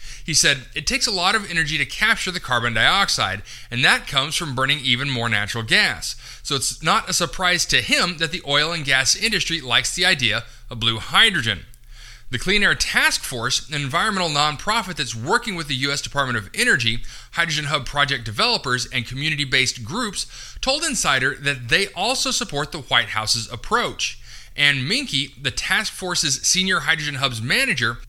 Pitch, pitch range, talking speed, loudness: 140 Hz, 120-170 Hz, 175 wpm, -19 LUFS